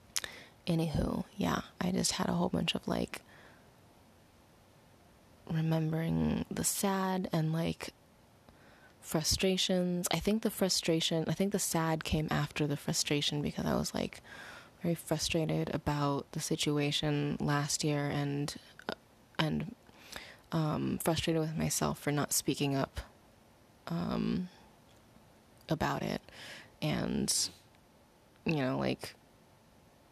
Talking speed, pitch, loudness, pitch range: 110 wpm, 155 Hz, -33 LUFS, 145-170 Hz